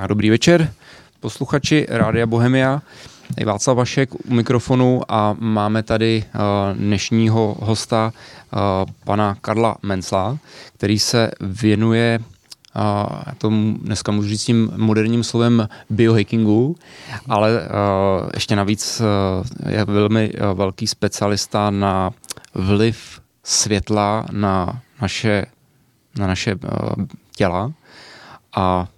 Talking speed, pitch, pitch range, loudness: 90 wpm, 110 Hz, 100-115 Hz, -18 LUFS